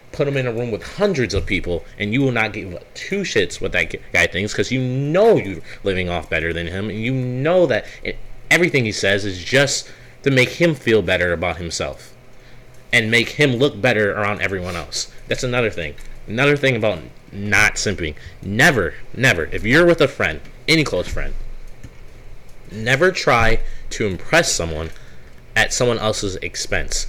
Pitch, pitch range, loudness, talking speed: 115 Hz, 95-135 Hz, -18 LUFS, 180 wpm